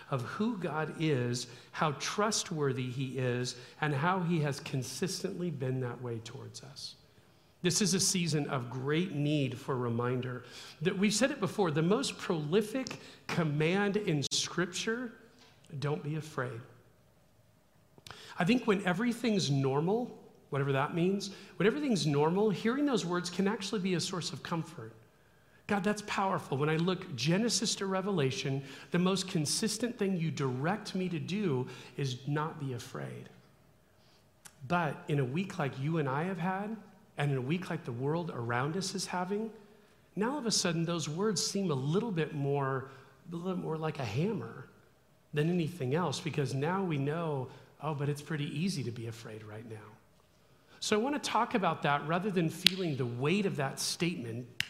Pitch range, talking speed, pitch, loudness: 135-190 Hz, 170 wpm, 160 Hz, -33 LUFS